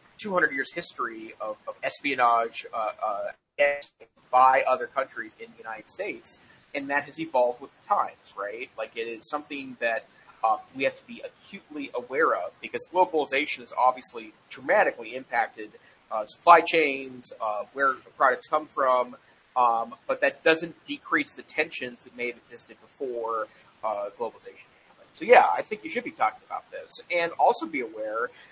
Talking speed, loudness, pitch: 165 wpm, -26 LUFS, 150 Hz